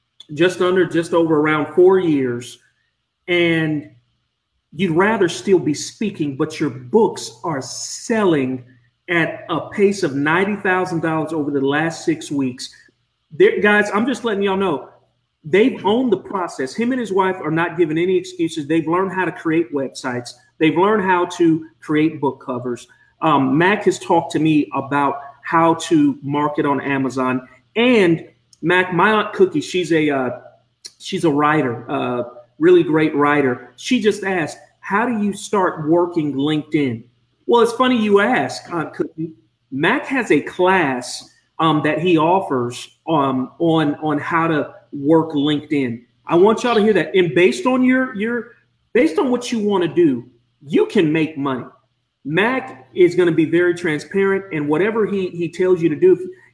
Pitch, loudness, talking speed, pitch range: 165 Hz, -18 LUFS, 170 wpm, 145-195 Hz